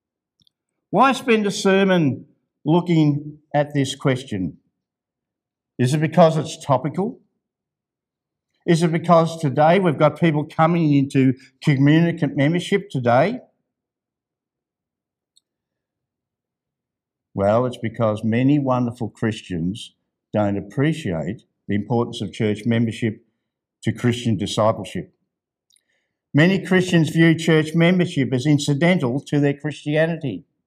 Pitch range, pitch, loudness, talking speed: 120-165 Hz, 145 Hz, -20 LUFS, 100 wpm